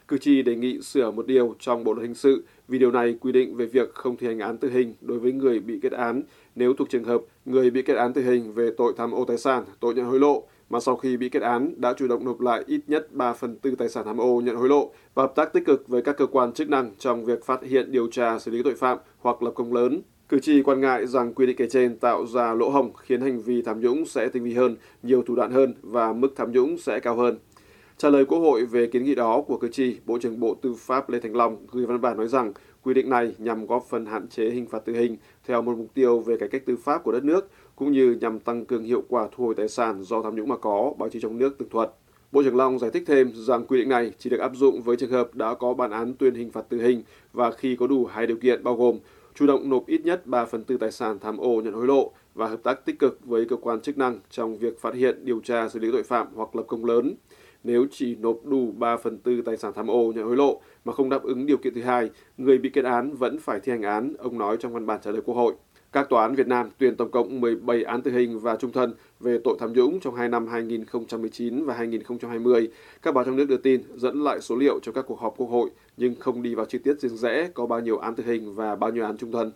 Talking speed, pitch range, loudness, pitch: 285 wpm, 115-130 Hz, -24 LUFS, 120 Hz